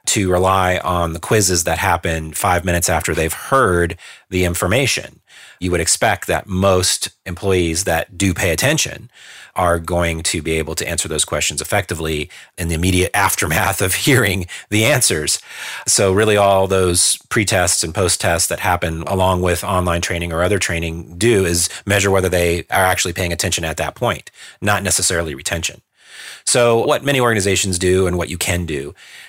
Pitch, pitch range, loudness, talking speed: 90 Hz, 85-100 Hz, -16 LUFS, 175 wpm